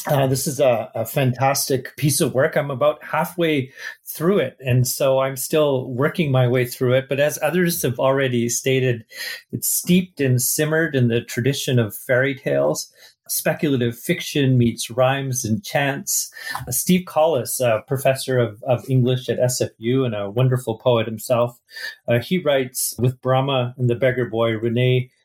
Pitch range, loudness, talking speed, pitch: 125-145 Hz, -20 LUFS, 165 wpm, 130 Hz